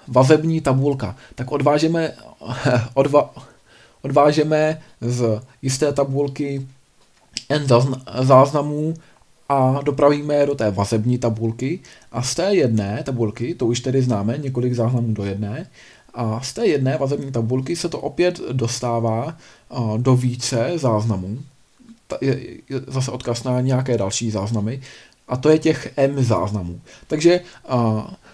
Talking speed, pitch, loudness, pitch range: 125 wpm, 130 Hz, -20 LUFS, 115-145 Hz